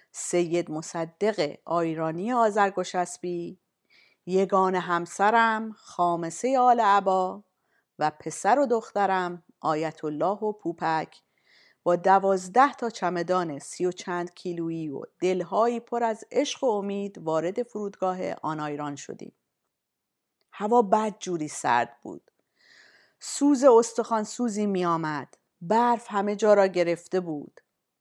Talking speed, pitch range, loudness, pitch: 115 wpm, 170-215 Hz, -26 LUFS, 185 Hz